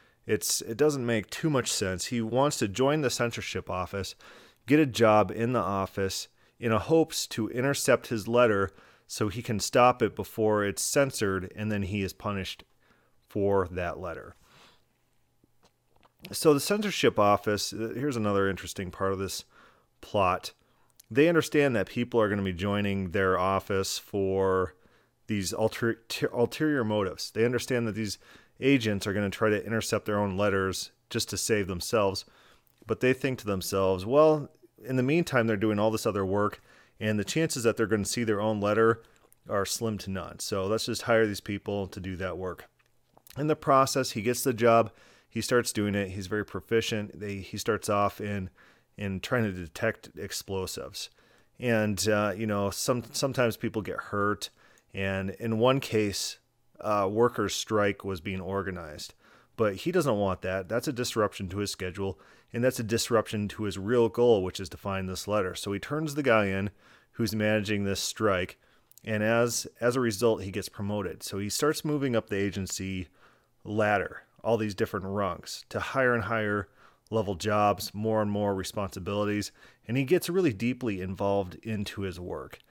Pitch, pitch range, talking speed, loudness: 105 Hz, 100-120 Hz, 180 wpm, -28 LUFS